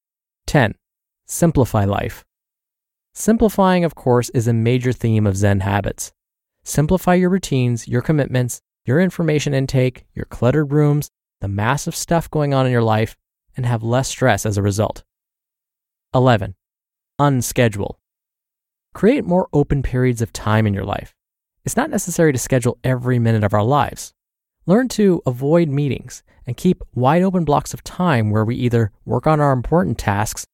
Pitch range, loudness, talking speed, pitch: 115-155 Hz, -18 LUFS, 155 wpm, 125 Hz